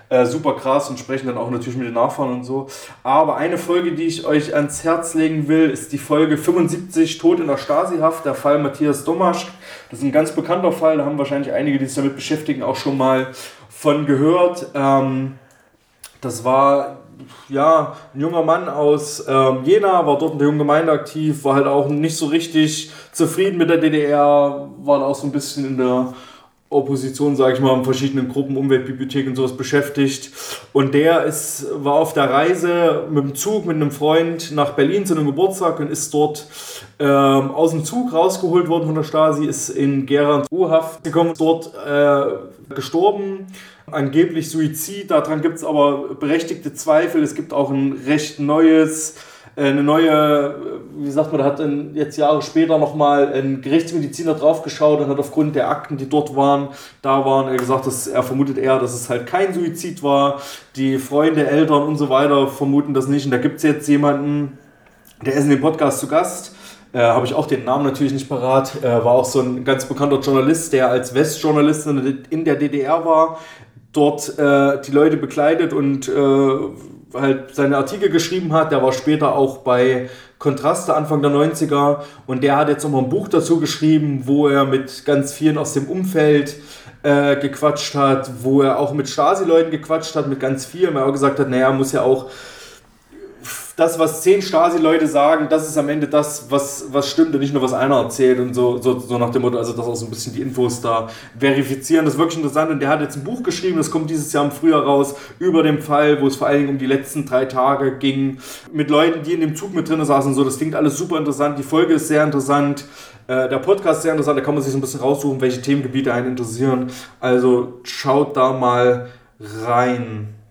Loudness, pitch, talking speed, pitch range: -17 LUFS, 145 Hz, 200 wpm, 135-155 Hz